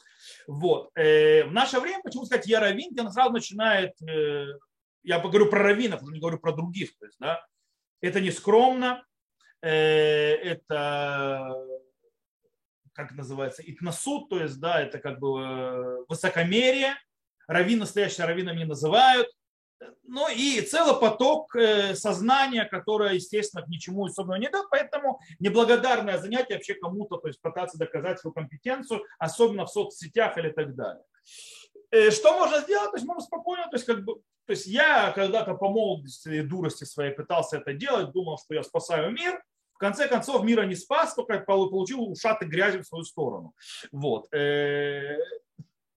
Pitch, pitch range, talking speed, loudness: 200 Hz, 160-255 Hz, 150 wpm, -26 LUFS